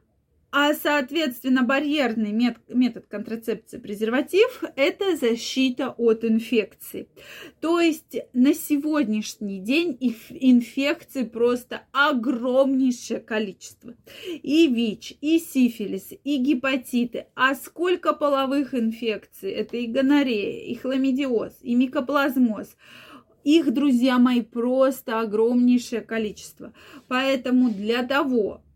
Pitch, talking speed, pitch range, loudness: 260 Hz, 95 wpm, 230-285 Hz, -23 LUFS